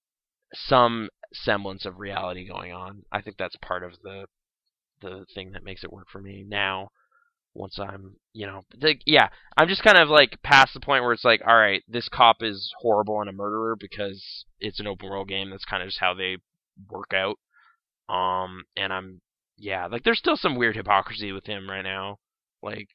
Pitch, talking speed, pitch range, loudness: 100 Hz, 200 wpm, 95-110 Hz, -23 LUFS